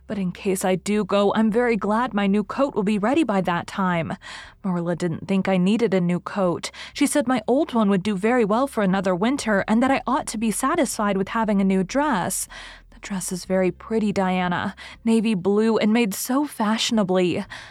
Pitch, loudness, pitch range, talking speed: 210 Hz, -22 LUFS, 190-230 Hz, 210 wpm